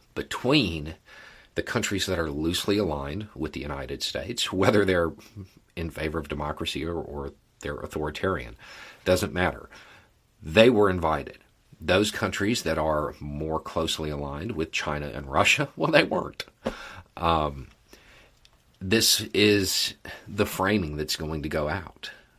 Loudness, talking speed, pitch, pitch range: -26 LUFS, 135 wpm, 80 Hz, 75-100 Hz